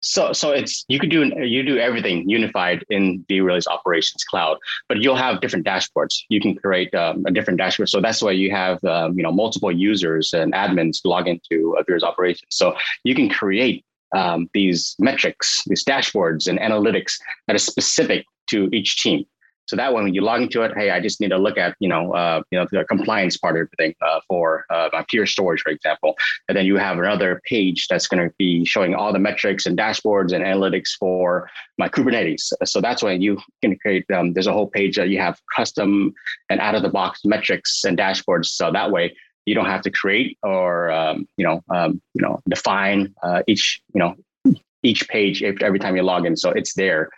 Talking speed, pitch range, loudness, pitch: 210 wpm, 85-95 Hz, -19 LUFS, 90 Hz